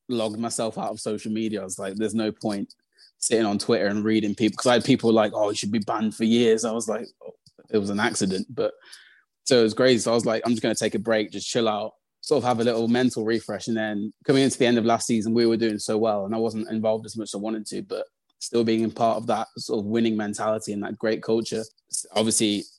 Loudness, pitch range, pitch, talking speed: -24 LUFS, 110-115 Hz, 110 Hz, 275 wpm